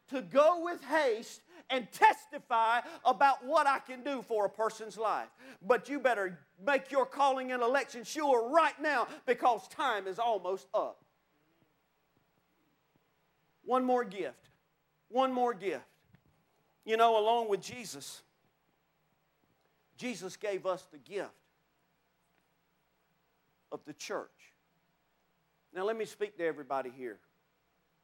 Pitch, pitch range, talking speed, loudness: 245 Hz, 210-280 Hz, 120 wpm, -32 LUFS